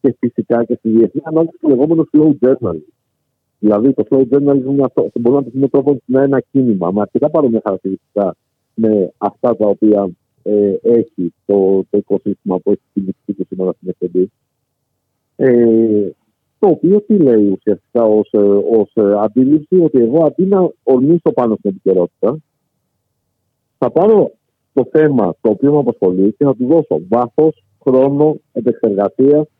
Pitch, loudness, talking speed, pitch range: 120 Hz, -14 LUFS, 150 wpm, 100-140 Hz